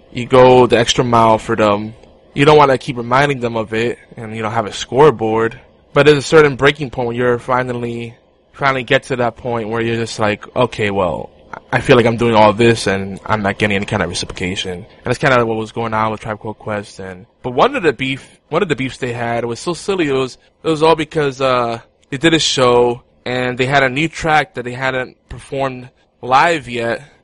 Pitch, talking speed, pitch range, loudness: 120 Hz, 240 wpm, 110-135 Hz, -15 LUFS